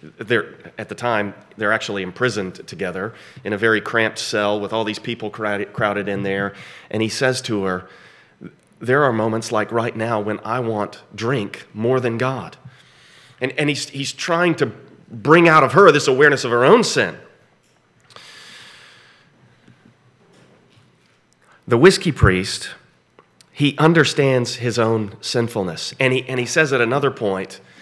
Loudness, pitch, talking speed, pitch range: -18 LUFS, 115 Hz, 150 wpm, 105-130 Hz